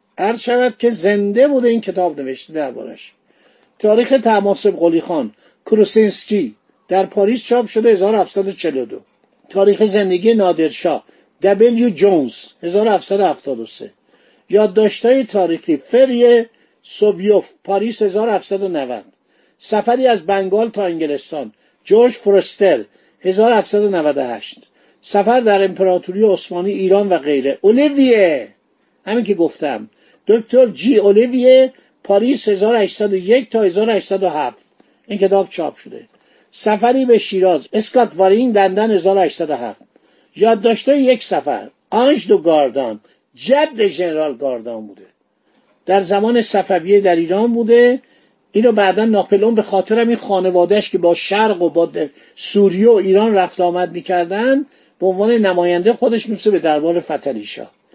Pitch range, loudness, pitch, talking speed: 185-230 Hz, -15 LUFS, 205 Hz, 115 wpm